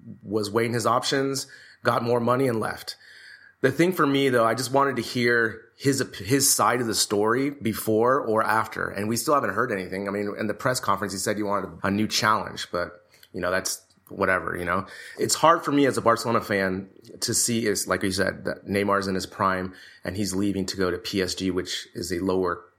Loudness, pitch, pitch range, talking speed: -24 LUFS, 105 Hz, 95-125 Hz, 220 wpm